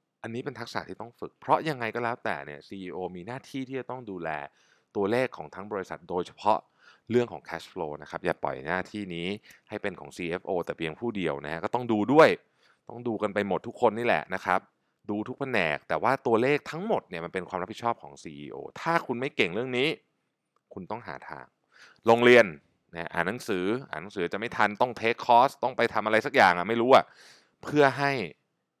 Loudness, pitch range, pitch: -27 LUFS, 90-120 Hz, 110 Hz